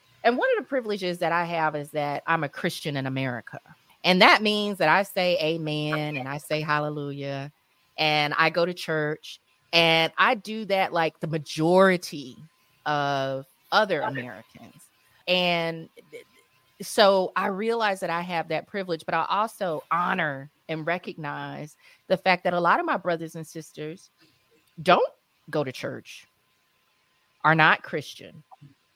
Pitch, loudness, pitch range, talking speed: 165 Hz, -24 LUFS, 150-185 Hz, 150 wpm